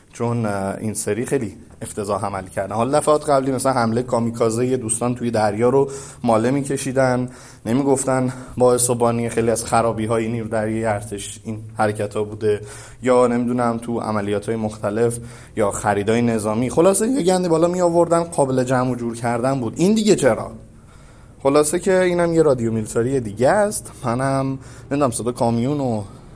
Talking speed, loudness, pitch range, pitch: 170 wpm, -20 LUFS, 110-135 Hz, 120 Hz